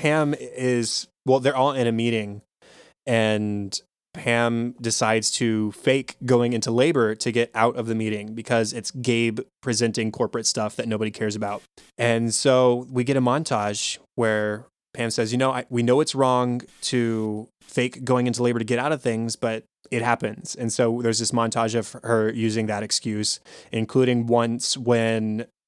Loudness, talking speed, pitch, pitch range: -23 LUFS, 175 wpm, 115 Hz, 110-125 Hz